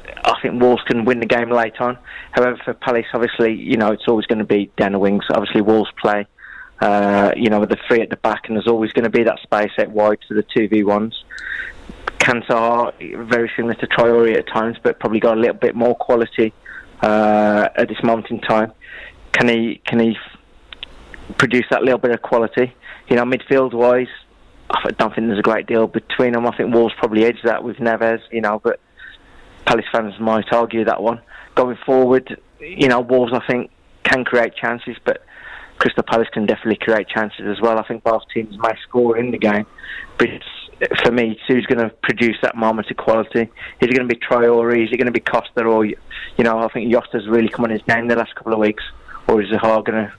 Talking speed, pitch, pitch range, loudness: 220 wpm, 115 Hz, 110-120 Hz, -17 LUFS